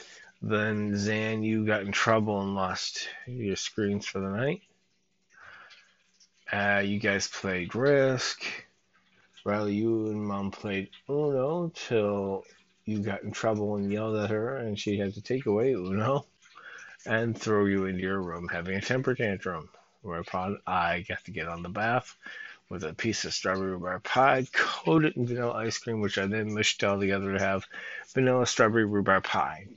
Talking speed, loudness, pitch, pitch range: 165 wpm, -29 LUFS, 105 Hz, 95-110 Hz